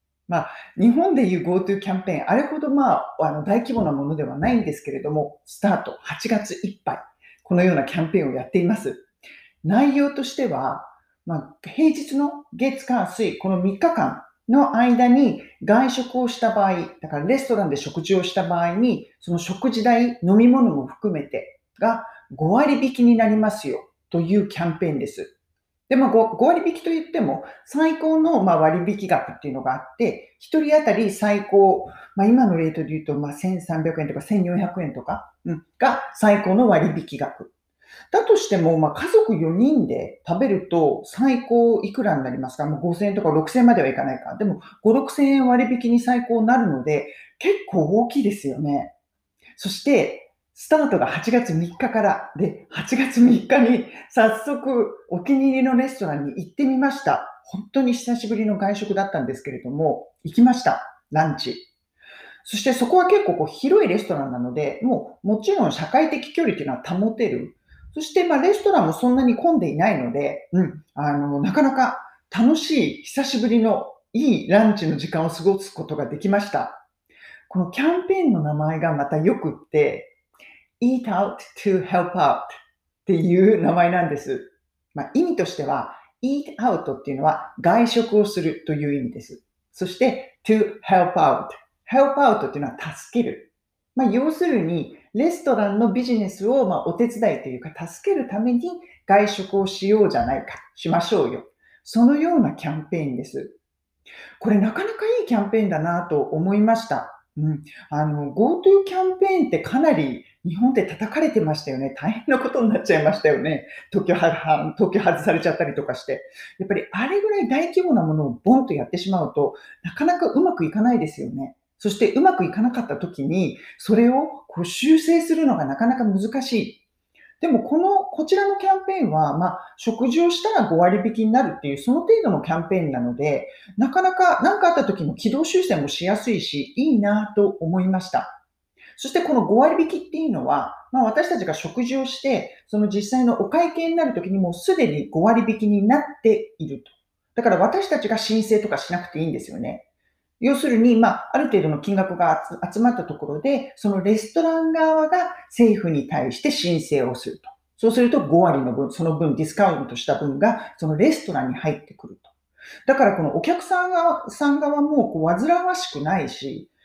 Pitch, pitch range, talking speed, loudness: 225 Hz, 175-275 Hz, 360 characters per minute, -21 LUFS